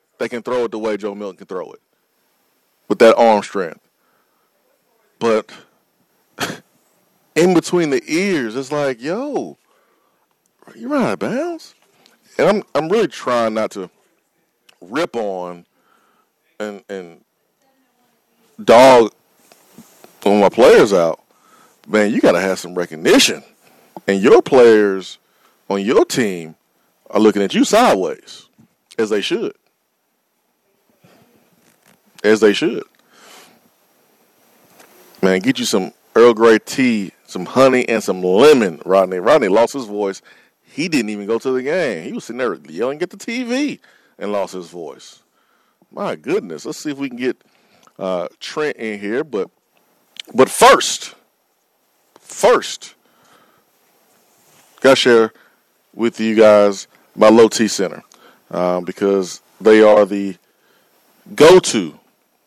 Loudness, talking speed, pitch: -15 LUFS, 130 wpm, 115 Hz